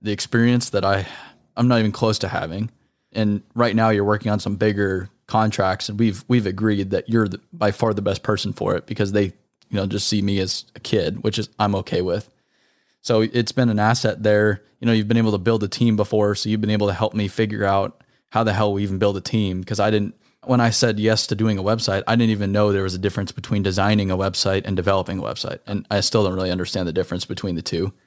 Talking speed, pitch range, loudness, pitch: 255 wpm, 100-110 Hz, -21 LUFS, 105 Hz